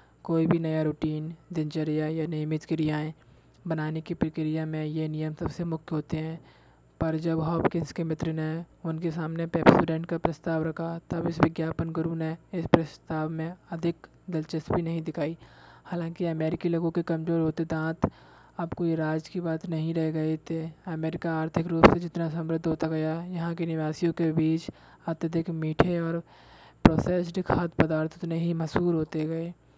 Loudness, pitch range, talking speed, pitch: -28 LUFS, 155-170 Hz, 165 wpm, 160 Hz